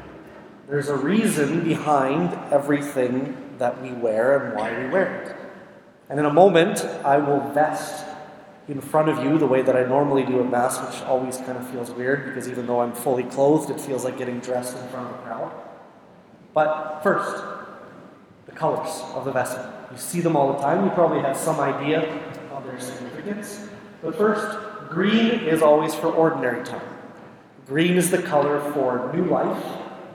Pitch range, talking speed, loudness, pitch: 130-160 Hz, 180 wpm, -22 LUFS, 145 Hz